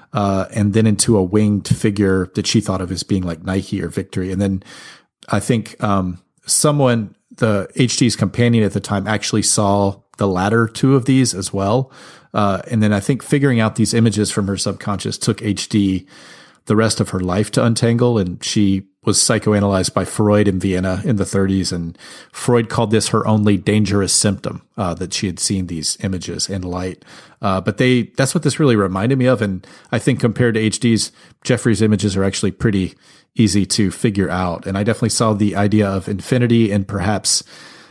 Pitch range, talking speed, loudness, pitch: 95-115 Hz, 195 wpm, -17 LUFS, 105 Hz